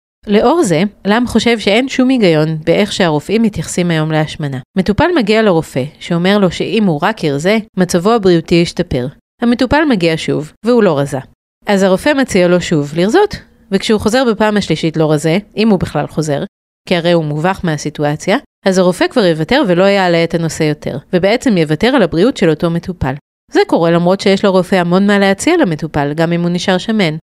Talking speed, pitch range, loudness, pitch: 175 wpm, 160-215 Hz, -13 LUFS, 185 Hz